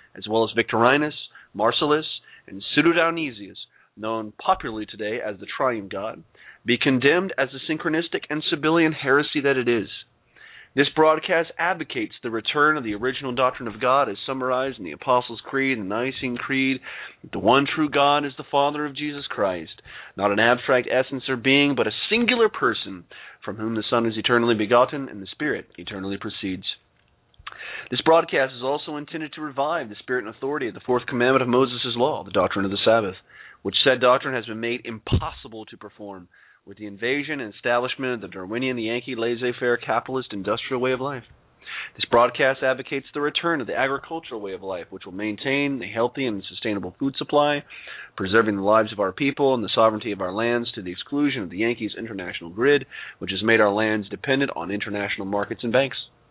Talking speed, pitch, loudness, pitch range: 190 wpm, 125 Hz, -23 LUFS, 110-140 Hz